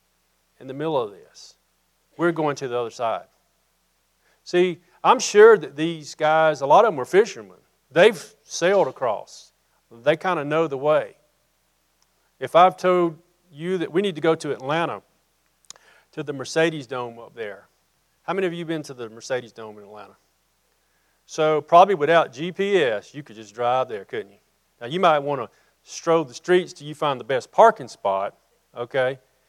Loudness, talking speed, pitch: -21 LUFS, 175 wpm, 140 Hz